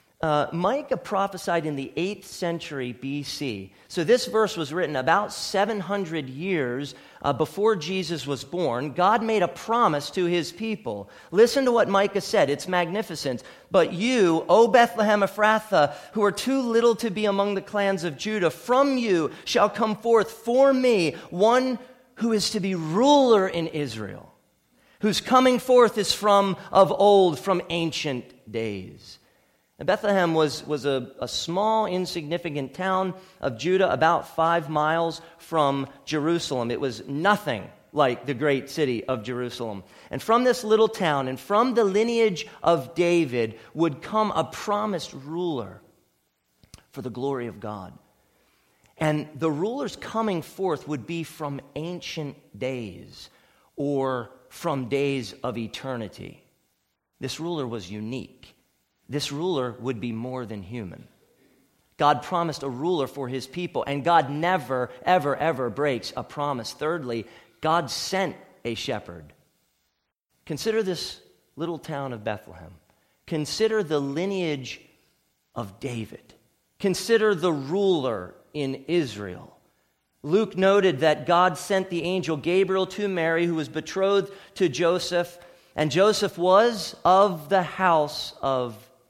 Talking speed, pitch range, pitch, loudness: 140 wpm, 135-195 Hz, 165 Hz, -24 LUFS